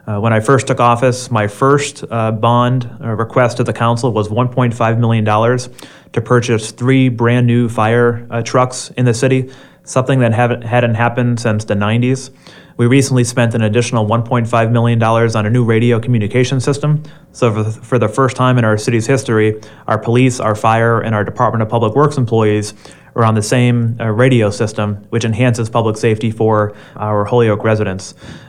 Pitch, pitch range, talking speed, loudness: 120 Hz, 110-125 Hz, 180 wpm, -14 LUFS